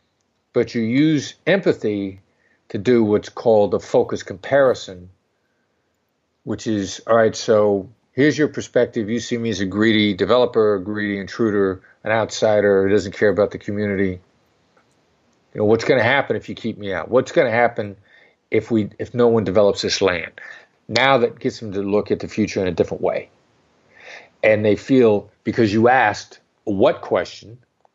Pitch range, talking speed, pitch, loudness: 100-120 Hz, 175 wpm, 105 Hz, -19 LUFS